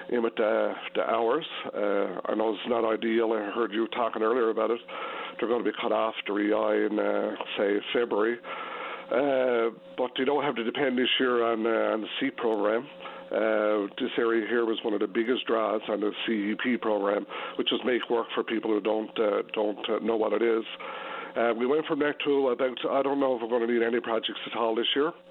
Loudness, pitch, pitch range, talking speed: -28 LUFS, 115 Hz, 110-120 Hz, 225 wpm